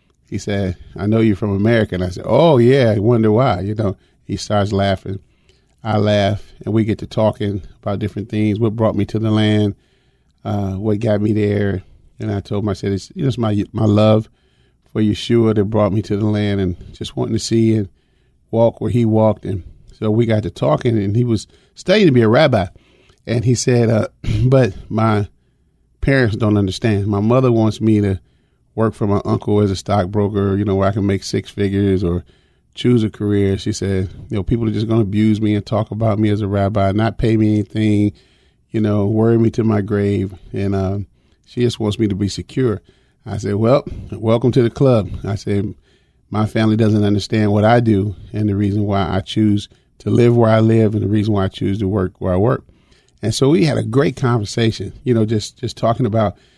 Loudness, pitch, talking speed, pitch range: -17 LUFS, 105 Hz, 220 wpm, 100-110 Hz